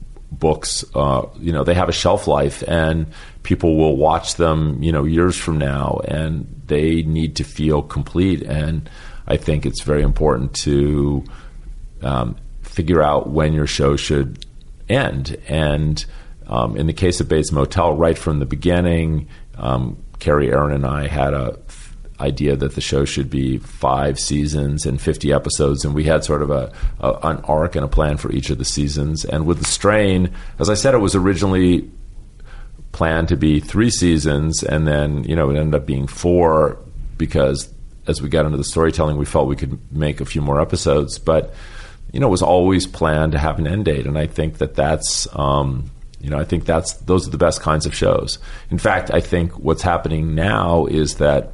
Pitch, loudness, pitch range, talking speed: 75 Hz, -18 LUFS, 70-85 Hz, 195 wpm